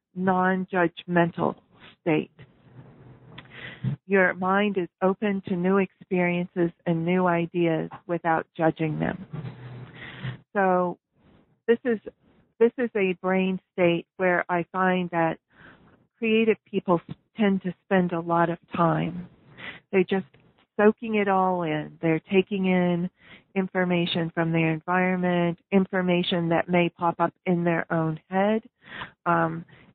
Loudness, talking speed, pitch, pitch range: -25 LUFS, 120 wpm, 175 Hz, 165-190 Hz